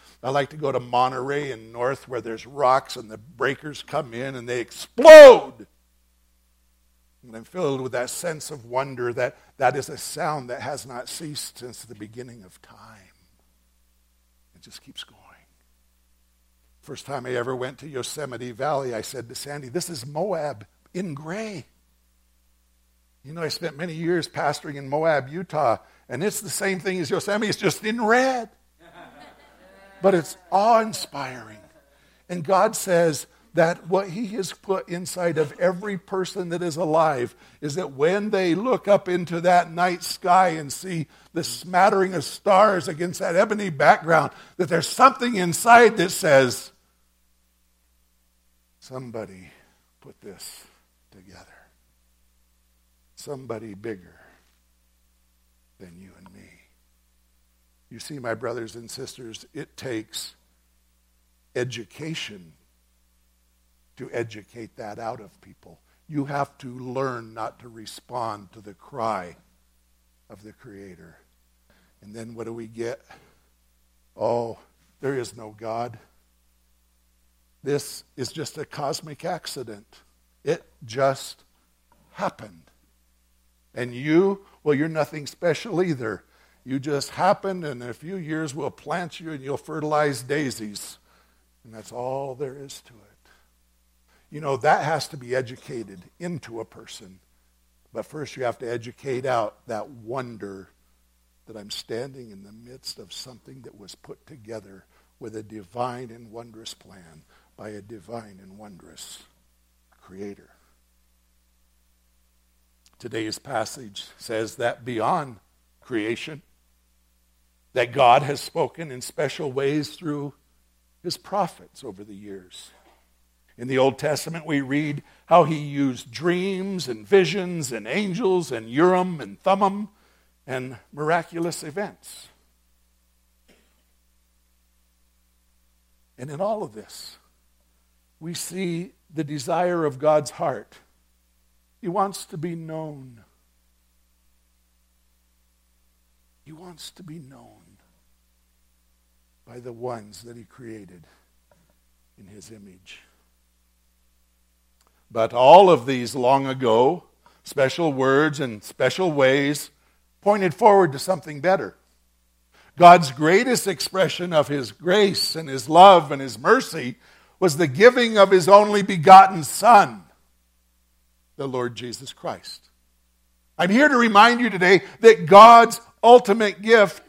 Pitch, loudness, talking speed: 120 Hz, -20 LUFS, 130 wpm